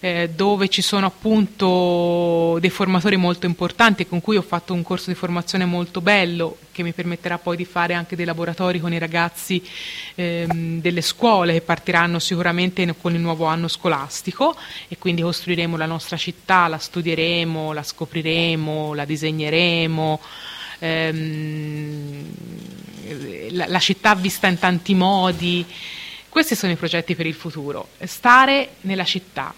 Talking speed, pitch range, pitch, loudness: 140 wpm, 165-185 Hz, 175 Hz, -20 LUFS